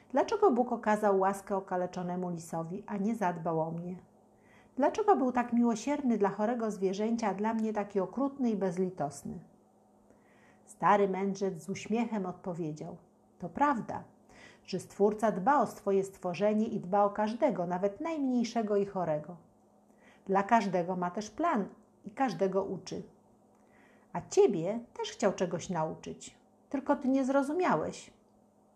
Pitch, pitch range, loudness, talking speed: 205 Hz, 185-235 Hz, -31 LUFS, 135 wpm